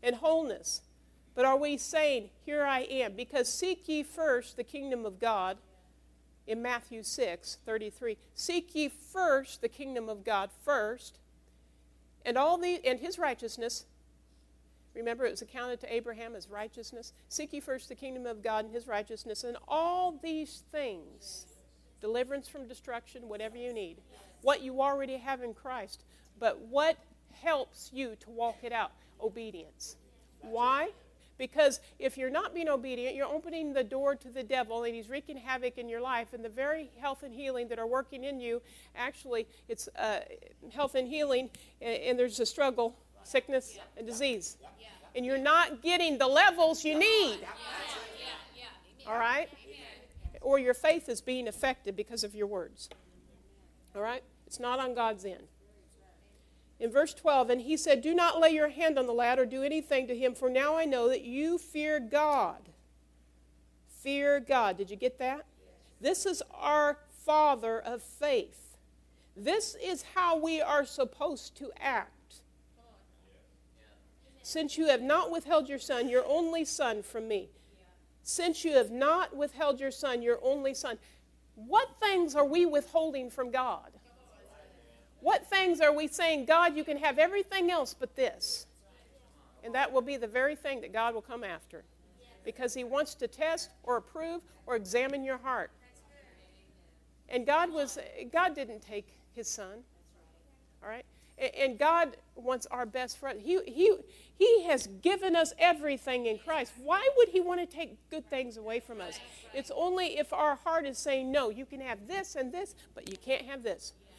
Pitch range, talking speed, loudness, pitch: 235-305 Hz, 165 wpm, -32 LUFS, 265 Hz